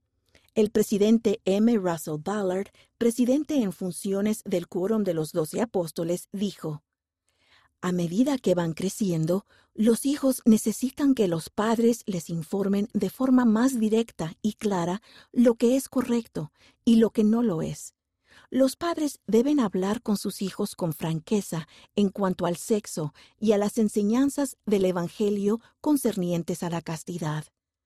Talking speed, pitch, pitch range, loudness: 145 wpm, 205 Hz, 175-230 Hz, -26 LUFS